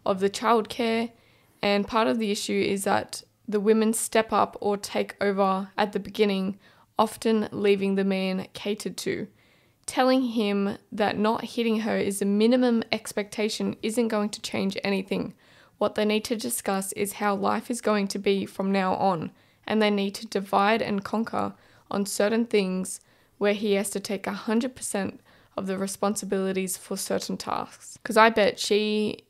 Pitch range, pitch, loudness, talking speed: 200-220 Hz, 205 Hz, -26 LUFS, 170 wpm